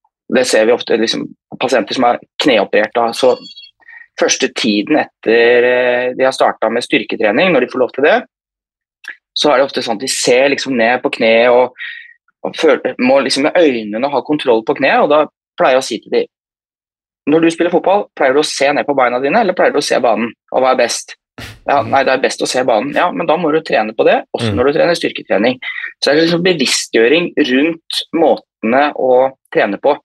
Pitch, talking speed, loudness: 150 Hz, 215 wpm, -13 LUFS